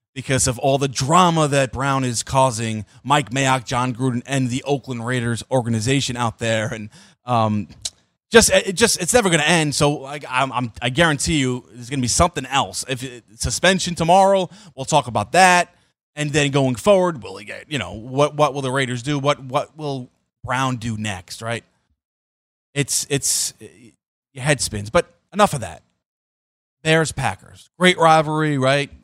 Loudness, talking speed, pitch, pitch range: -19 LUFS, 180 wpm, 135 Hz, 120-155 Hz